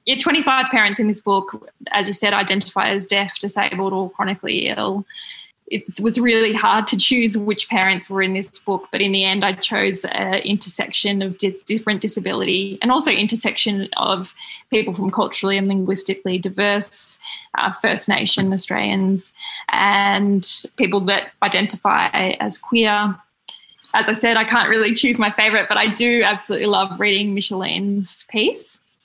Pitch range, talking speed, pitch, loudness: 195-220 Hz, 160 wpm, 205 Hz, -18 LUFS